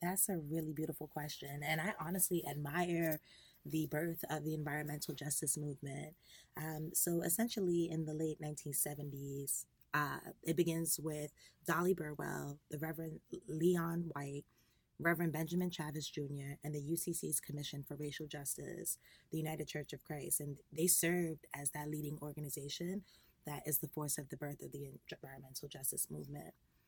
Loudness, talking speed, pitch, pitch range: -40 LUFS, 150 wpm, 155 Hz, 145-165 Hz